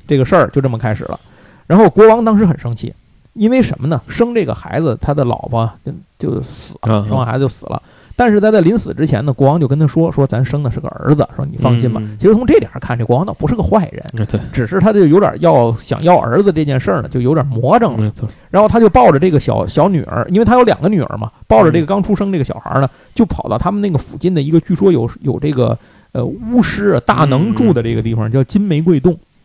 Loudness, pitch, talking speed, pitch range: -13 LUFS, 150 Hz, 365 characters per minute, 125-190 Hz